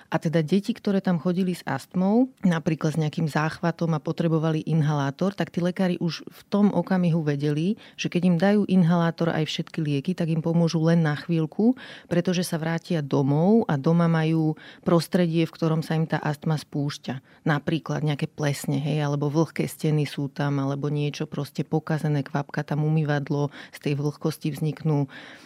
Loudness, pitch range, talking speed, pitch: -25 LUFS, 150-175 Hz, 170 wpm, 160 Hz